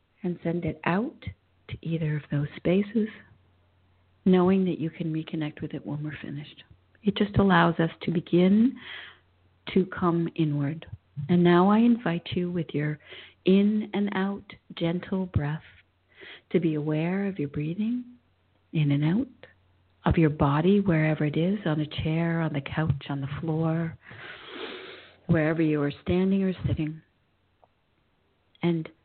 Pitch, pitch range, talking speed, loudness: 160 Hz, 145-180 Hz, 145 wpm, -26 LUFS